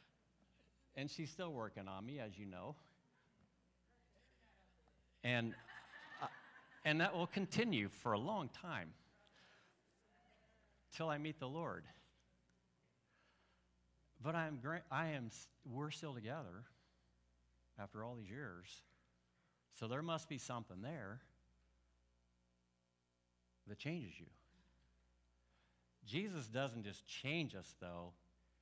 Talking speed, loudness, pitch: 105 wpm, -46 LUFS, 95 Hz